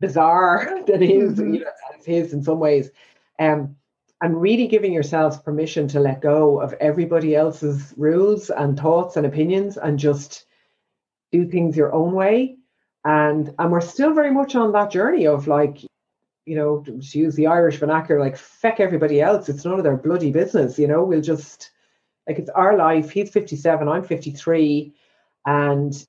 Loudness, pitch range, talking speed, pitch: -19 LUFS, 150-175 Hz, 165 wpm, 155 Hz